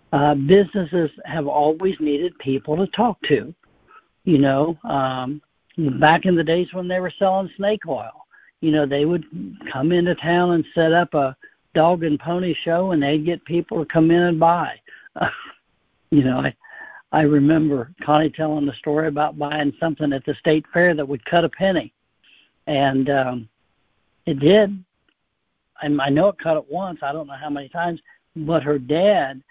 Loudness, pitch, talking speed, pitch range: -20 LUFS, 155 Hz, 180 wpm, 145-175 Hz